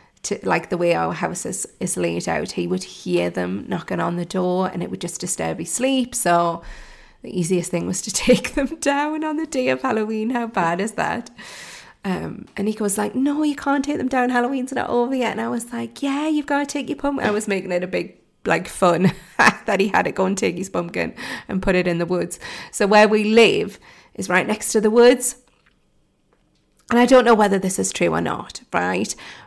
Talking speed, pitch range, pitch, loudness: 230 wpm, 180-255 Hz, 215 Hz, -20 LUFS